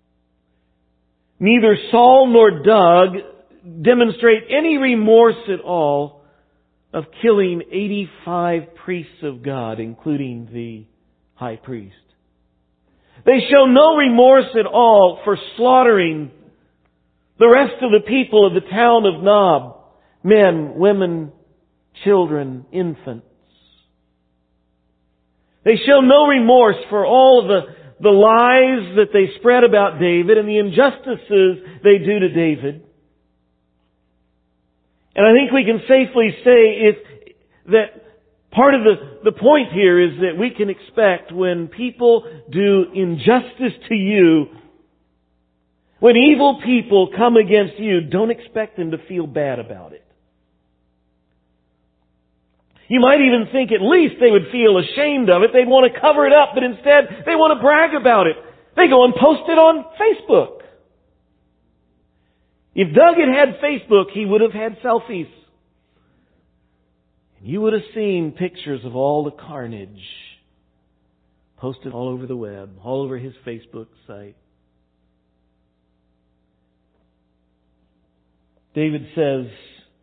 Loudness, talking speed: -14 LUFS, 125 wpm